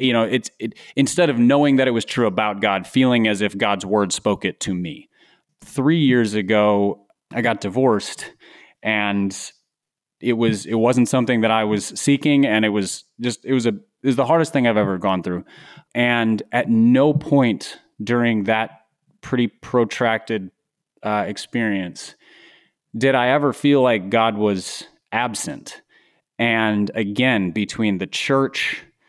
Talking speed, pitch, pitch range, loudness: 160 wpm, 115 Hz, 105-130 Hz, -19 LUFS